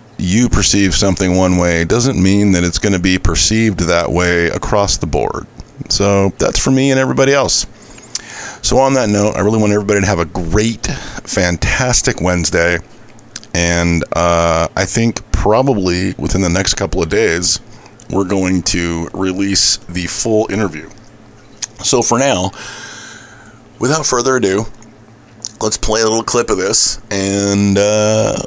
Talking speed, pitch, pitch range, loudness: 150 wpm, 100 Hz, 90-110 Hz, -13 LUFS